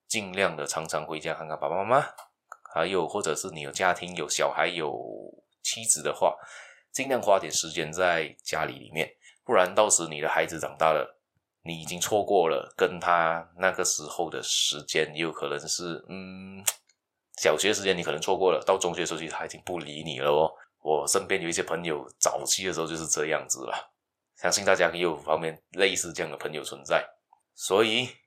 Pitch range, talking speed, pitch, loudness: 80-95 Hz, 285 characters per minute, 85 Hz, -27 LUFS